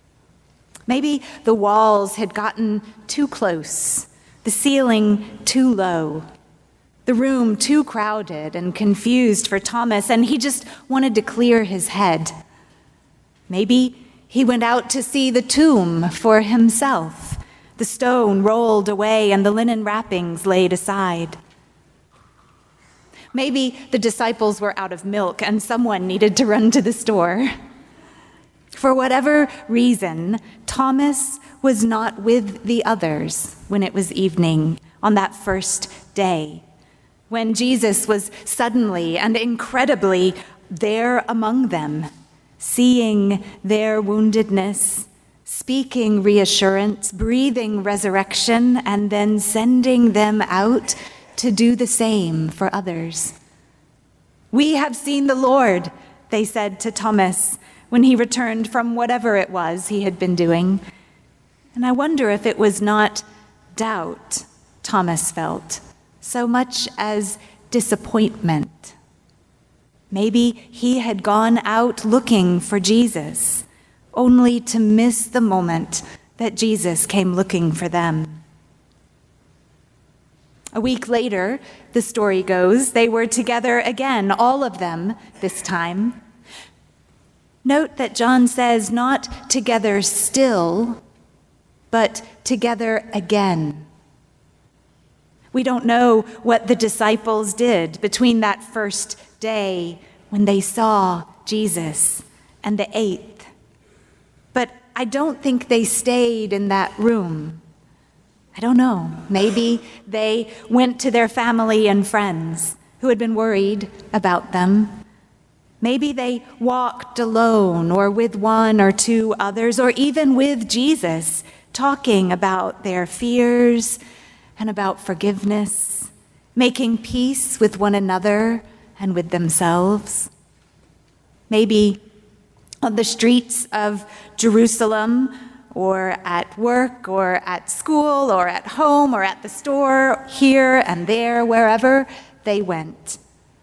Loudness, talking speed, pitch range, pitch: -18 LUFS, 120 wpm, 195-245 Hz, 220 Hz